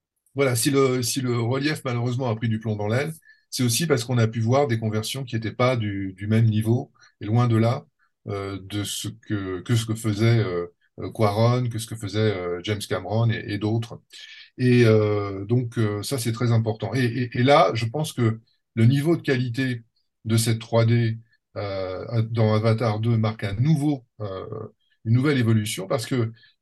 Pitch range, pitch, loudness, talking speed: 110-125 Hz, 115 Hz, -23 LUFS, 200 wpm